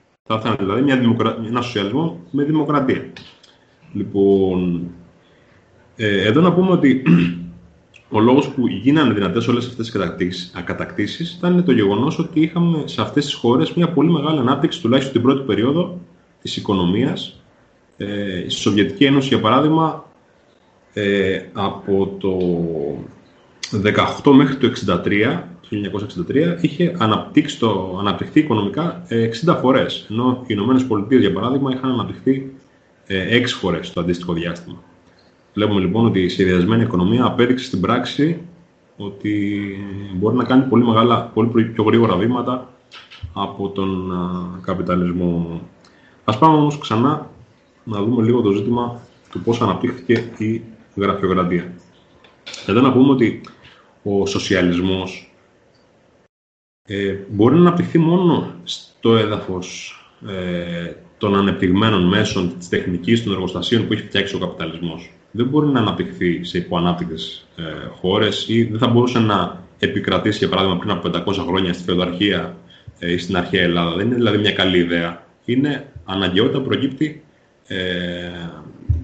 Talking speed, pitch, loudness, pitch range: 135 wpm, 105 Hz, -18 LUFS, 90-130 Hz